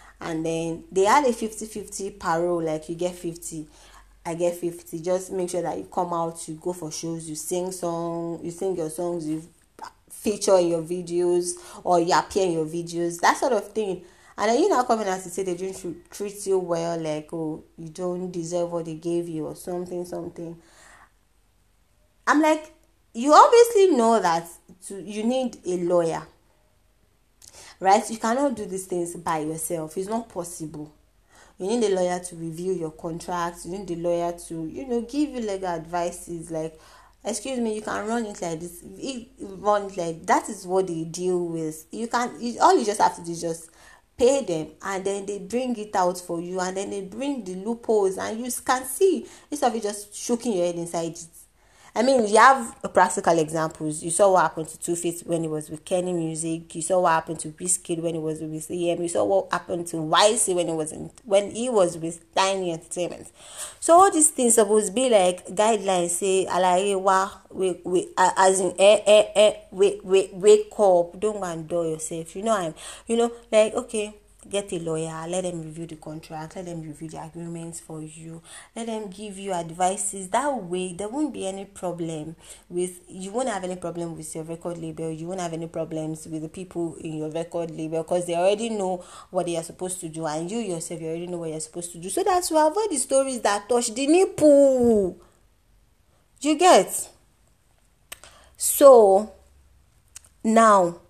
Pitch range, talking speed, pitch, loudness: 170-210 Hz, 200 wpm, 180 Hz, -24 LUFS